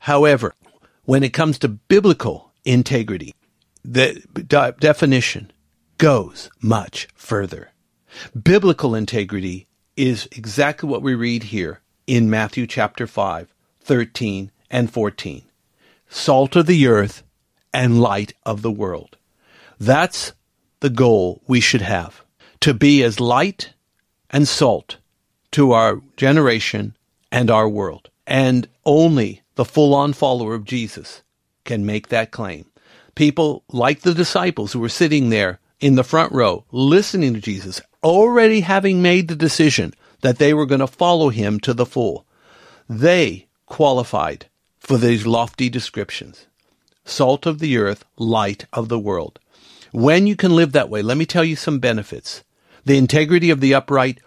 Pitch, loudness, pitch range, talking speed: 130 Hz, -17 LUFS, 110-150 Hz, 140 wpm